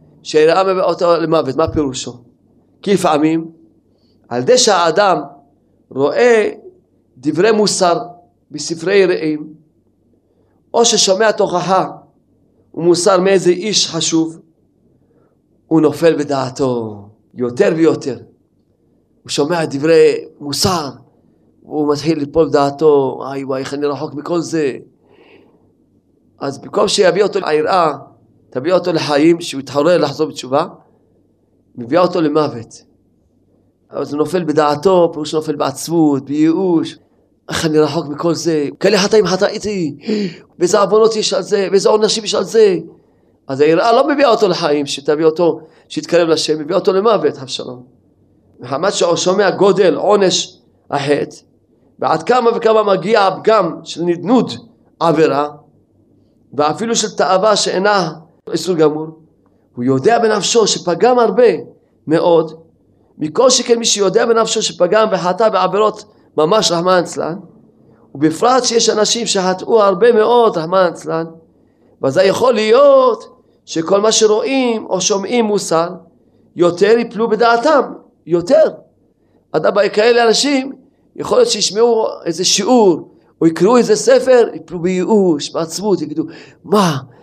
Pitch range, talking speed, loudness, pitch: 150-210 Hz, 120 wpm, -14 LUFS, 175 Hz